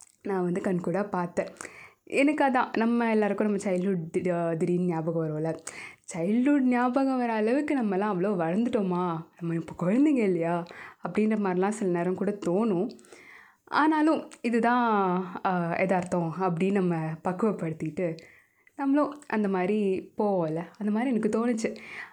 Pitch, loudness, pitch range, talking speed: 195 Hz, -27 LUFS, 175-230 Hz, 120 wpm